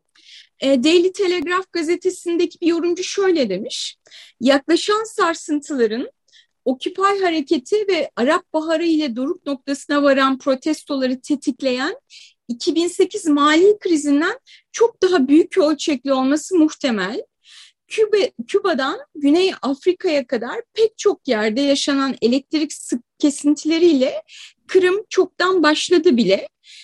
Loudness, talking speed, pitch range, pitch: -18 LUFS, 100 wpm, 280-370 Hz, 320 Hz